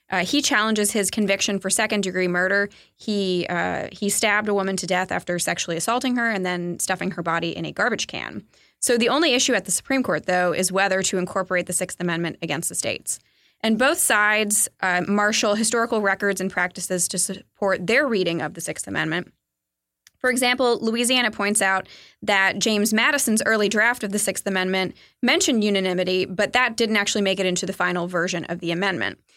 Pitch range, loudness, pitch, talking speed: 185-220 Hz, -21 LUFS, 195 Hz, 195 wpm